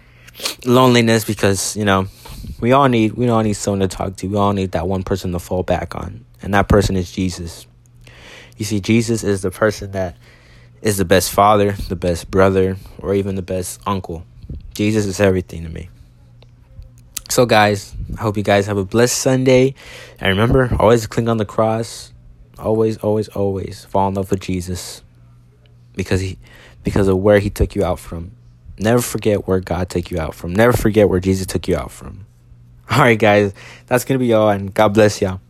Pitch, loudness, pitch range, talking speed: 100 Hz, -17 LUFS, 95-115 Hz, 195 wpm